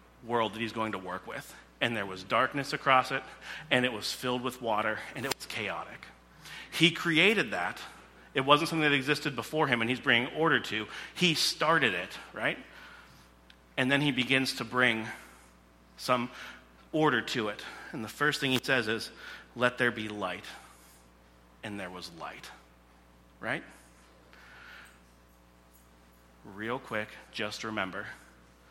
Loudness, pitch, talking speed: -30 LUFS, 110 Hz, 150 wpm